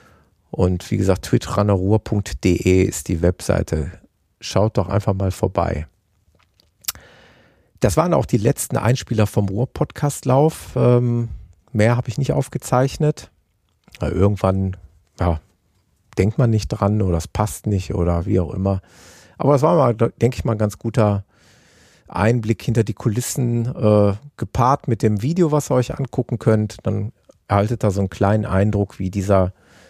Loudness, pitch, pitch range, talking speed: -20 LUFS, 105 Hz, 95-120 Hz, 150 wpm